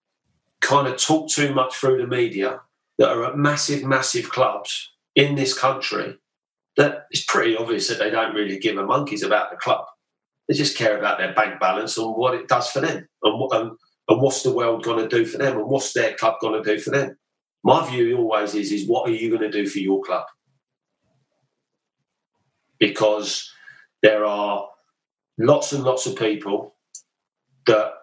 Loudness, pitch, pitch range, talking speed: -21 LUFS, 130 Hz, 110-140 Hz, 180 wpm